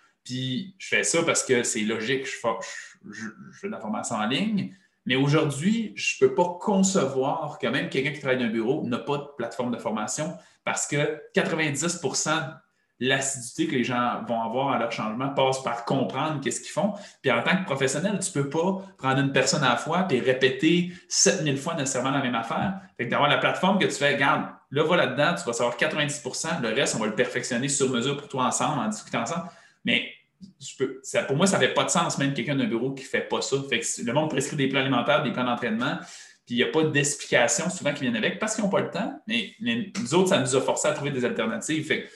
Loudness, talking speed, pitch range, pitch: -25 LUFS, 240 wpm, 135-185 Hz, 145 Hz